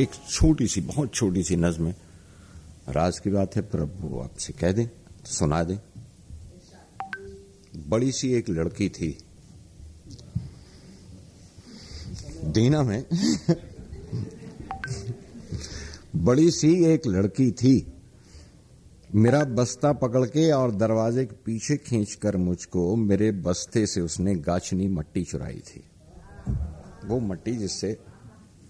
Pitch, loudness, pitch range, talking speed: 105 Hz, -25 LUFS, 90-125 Hz, 105 wpm